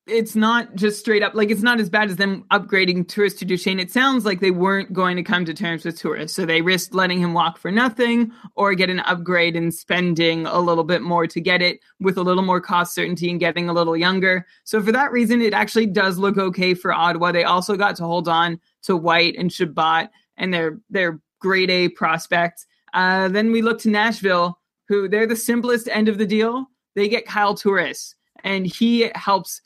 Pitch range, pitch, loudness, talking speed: 175-215 Hz, 190 Hz, -19 LUFS, 220 wpm